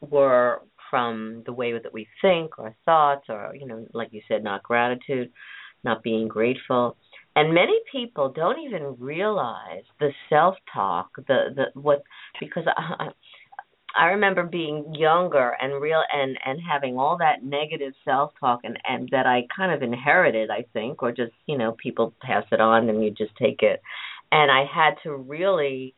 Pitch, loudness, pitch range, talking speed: 135 Hz, -23 LUFS, 120-155 Hz, 175 wpm